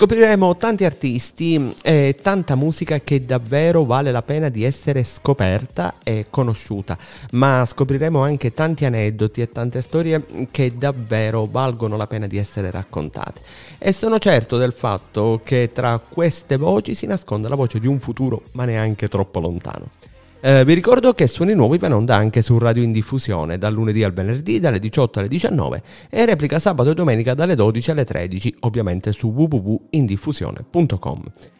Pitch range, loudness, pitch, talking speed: 110-155 Hz, -18 LUFS, 125 Hz, 160 wpm